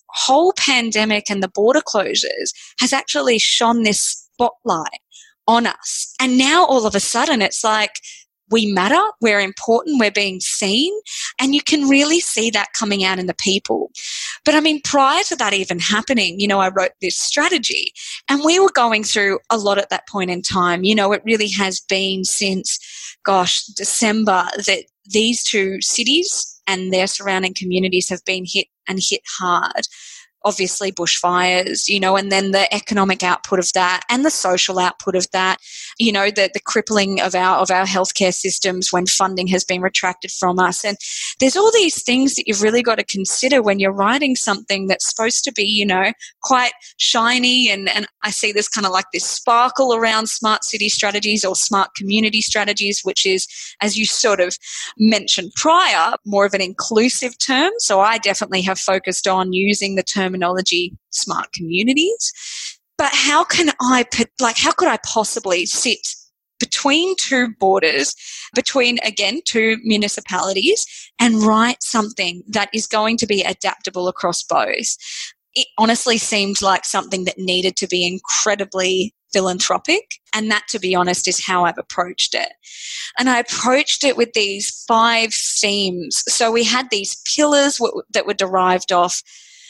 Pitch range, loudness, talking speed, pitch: 190-250 Hz, -17 LUFS, 170 wpm, 210 Hz